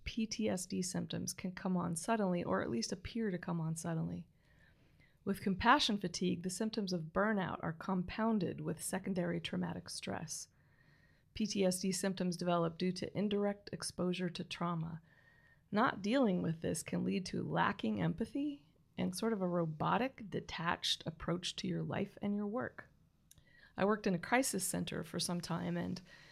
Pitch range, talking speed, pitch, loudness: 170-205 Hz, 155 wpm, 185 Hz, -37 LUFS